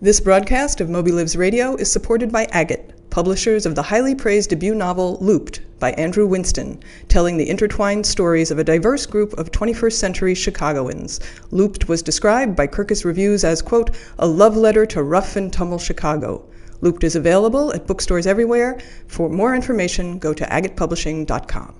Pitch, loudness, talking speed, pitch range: 190 Hz, -18 LUFS, 170 wpm, 165-215 Hz